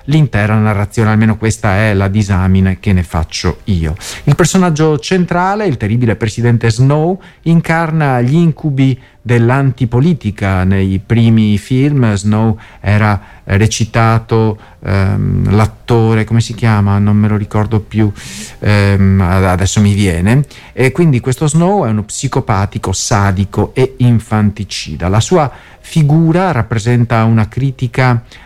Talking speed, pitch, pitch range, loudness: 120 wpm, 110 Hz, 100-130 Hz, -12 LUFS